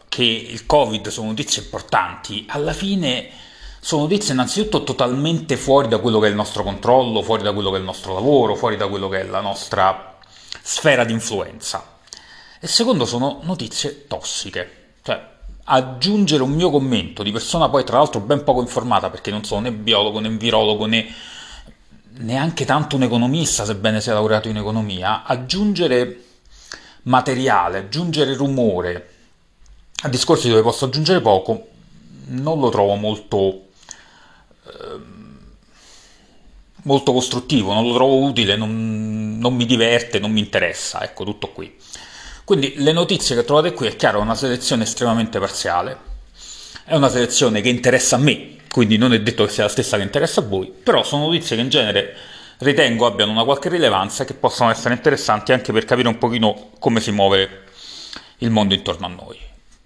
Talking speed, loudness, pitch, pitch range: 165 wpm, -18 LUFS, 120 Hz, 105-135 Hz